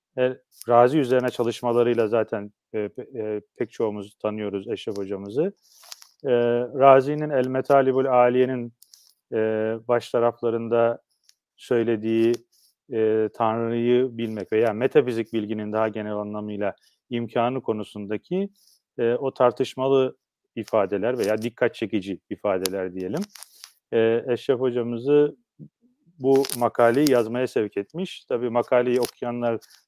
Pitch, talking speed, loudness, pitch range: 120 Hz, 105 wpm, -24 LUFS, 110-130 Hz